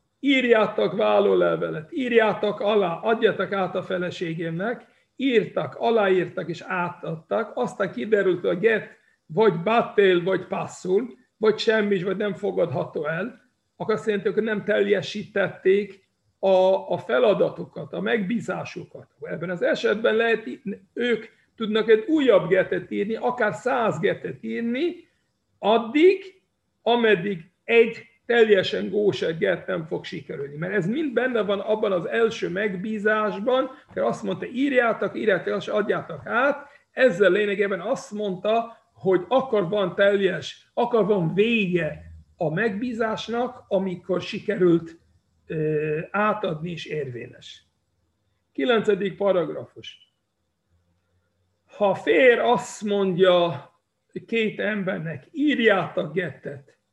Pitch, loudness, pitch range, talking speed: 205 Hz, -23 LUFS, 180-225 Hz, 110 wpm